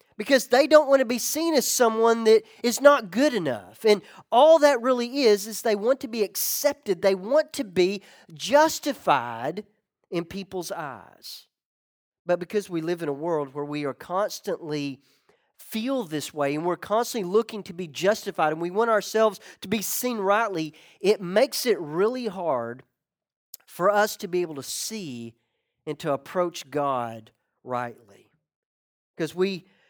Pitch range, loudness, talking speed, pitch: 155-230 Hz, -24 LUFS, 165 wpm, 195 Hz